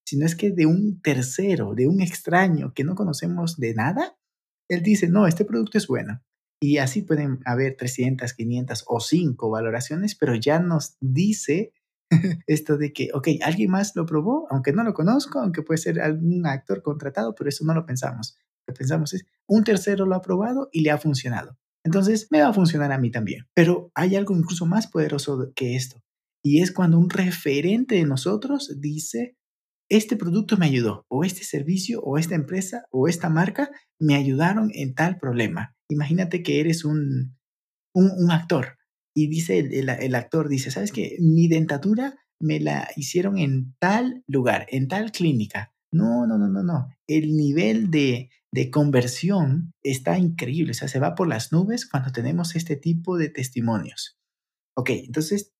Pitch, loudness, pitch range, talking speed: 160 Hz, -23 LUFS, 135-190 Hz, 180 wpm